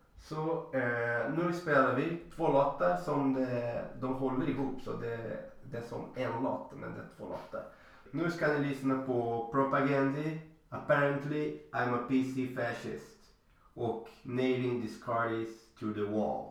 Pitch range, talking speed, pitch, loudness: 120-145 Hz, 155 wpm, 130 Hz, -33 LUFS